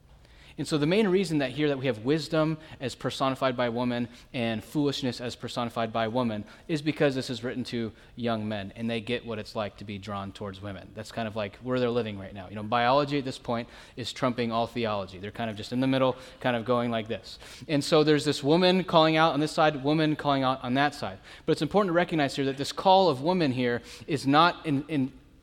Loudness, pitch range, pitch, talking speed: -27 LUFS, 115-145 Hz, 125 Hz, 245 wpm